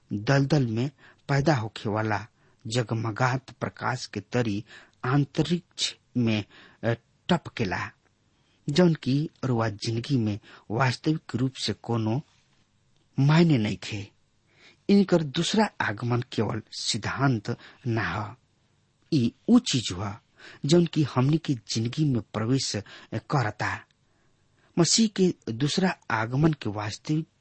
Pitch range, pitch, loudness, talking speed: 110-145 Hz, 120 Hz, -27 LUFS, 95 wpm